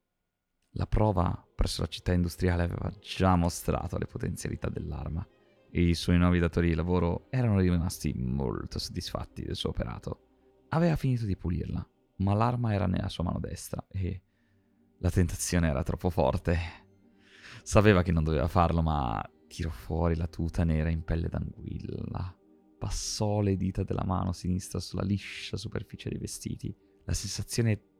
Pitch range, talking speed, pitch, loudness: 85-100 Hz, 150 wpm, 90 Hz, -30 LUFS